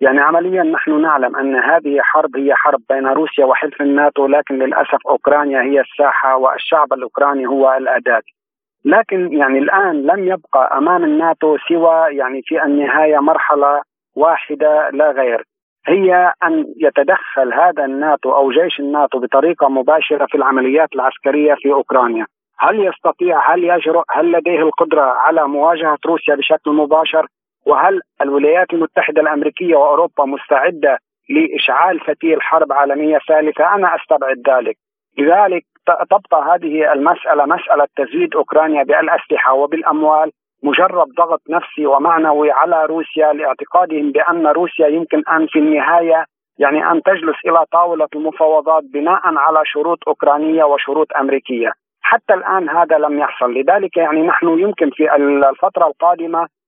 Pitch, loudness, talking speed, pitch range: 155 Hz, -14 LUFS, 130 wpm, 145-170 Hz